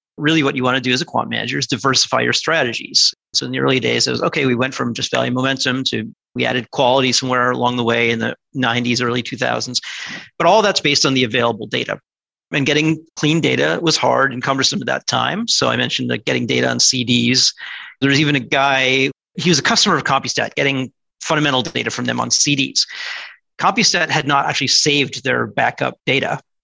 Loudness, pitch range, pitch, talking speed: -16 LUFS, 125-145 Hz, 135 Hz, 215 wpm